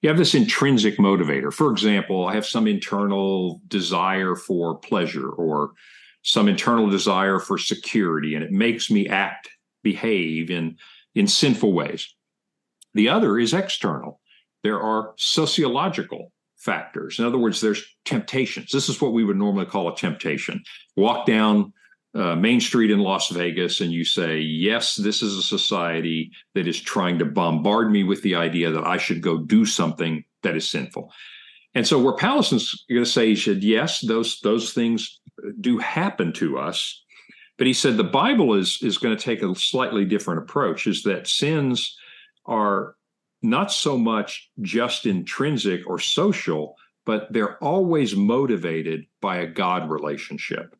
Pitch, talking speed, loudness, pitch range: 105 Hz, 160 wpm, -22 LUFS, 85-125 Hz